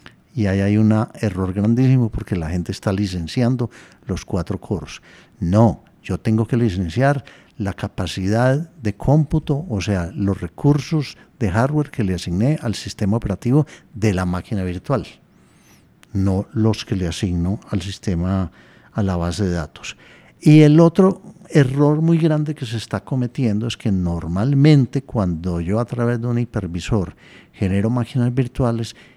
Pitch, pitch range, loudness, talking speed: 110 Hz, 95-130 Hz, -19 LUFS, 150 wpm